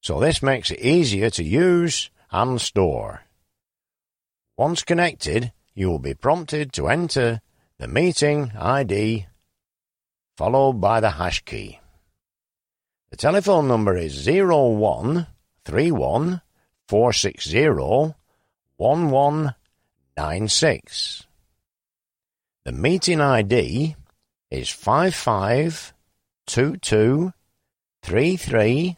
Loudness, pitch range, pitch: -21 LUFS, 105-160 Hz, 130 Hz